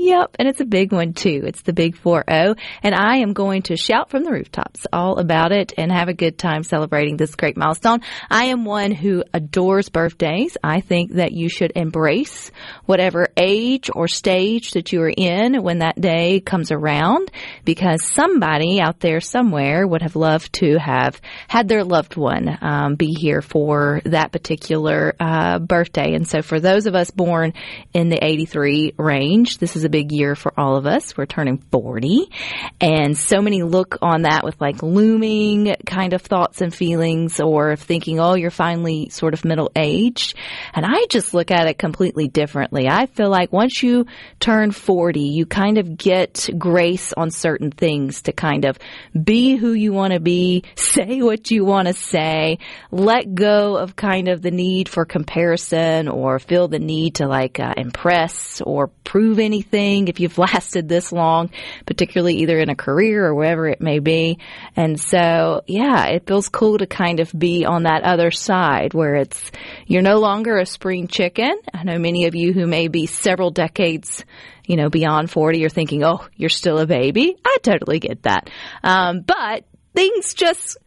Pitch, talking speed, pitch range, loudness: 175 Hz, 185 wpm, 160-200 Hz, -18 LUFS